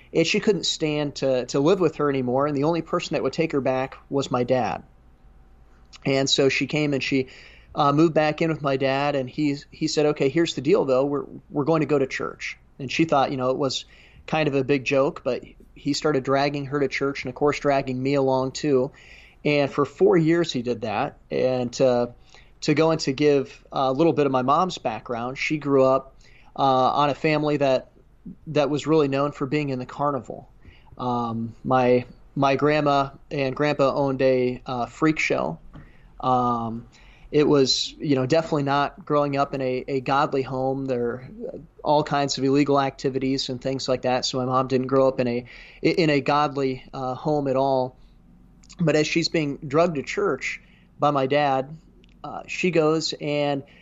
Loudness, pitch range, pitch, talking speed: -23 LUFS, 130-150 Hz, 140 Hz, 200 wpm